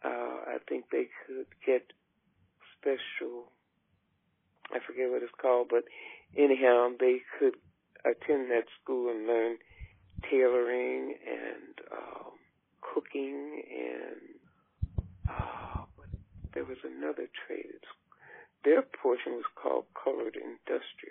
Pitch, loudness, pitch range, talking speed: 125 Hz, -32 LUFS, 115-150 Hz, 105 wpm